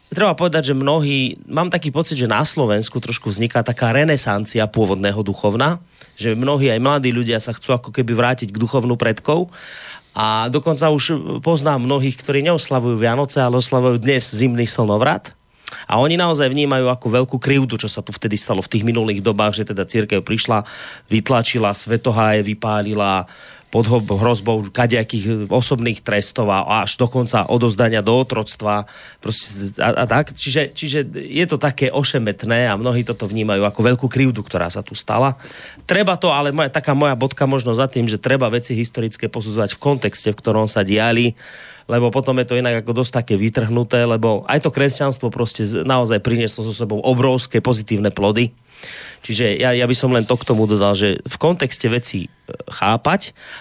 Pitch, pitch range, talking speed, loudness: 120 Hz, 110-135 Hz, 170 wpm, -18 LUFS